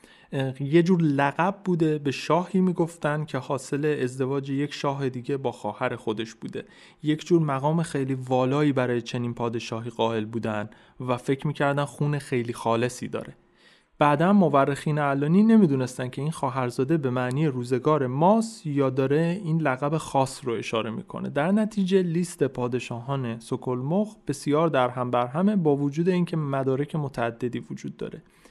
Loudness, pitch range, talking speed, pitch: -25 LUFS, 125-160 Hz, 145 wpm, 140 Hz